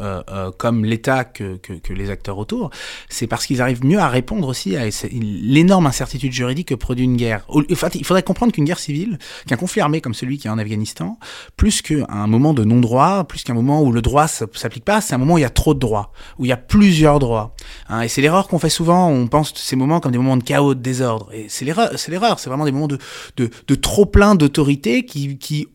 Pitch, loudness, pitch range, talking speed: 130 Hz, -17 LUFS, 115-150 Hz, 250 wpm